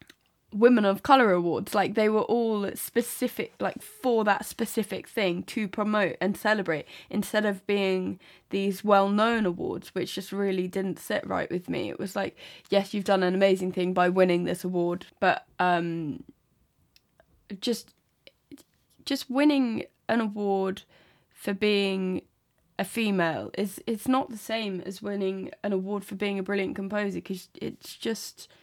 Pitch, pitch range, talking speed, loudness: 200 Hz, 185-220 Hz, 155 wpm, -27 LUFS